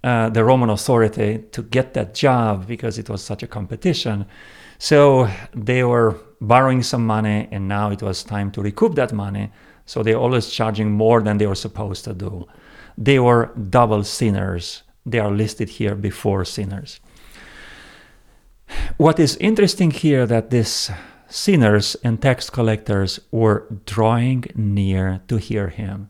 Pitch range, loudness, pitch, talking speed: 105-120 Hz, -19 LUFS, 110 Hz, 150 wpm